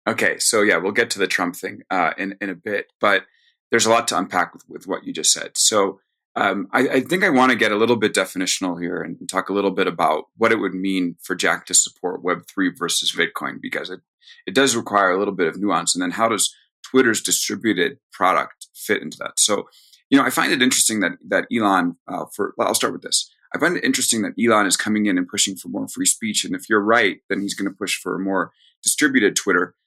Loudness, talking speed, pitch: -19 LUFS, 250 wpm, 110 Hz